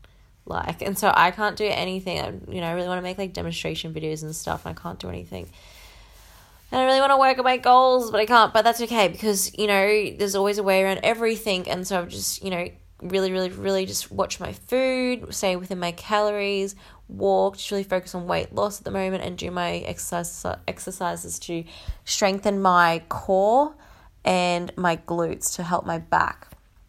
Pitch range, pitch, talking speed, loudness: 165-210 Hz, 190 Hz, 210 wpm, -23 LUFS